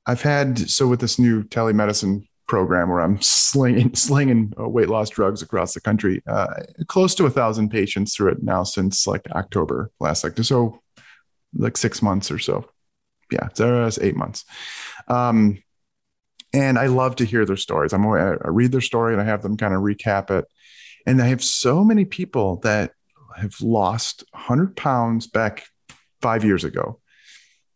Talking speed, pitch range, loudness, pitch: 170 wpm, 100-125 Hz, -20 LUFS, 115 Hz